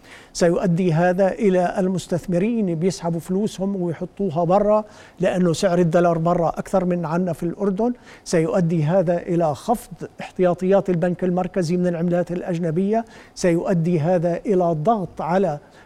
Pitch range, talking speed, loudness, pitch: 175-195 Hz, 120 wpm, -21 LUFS, 180 Hz